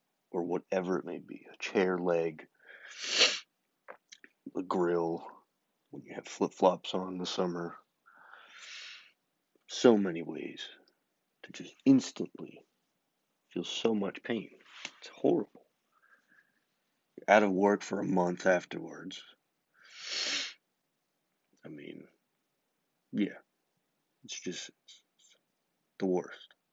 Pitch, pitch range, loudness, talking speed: 90 Hz, 85-105 Hz, -32 LUFS, 110 wpm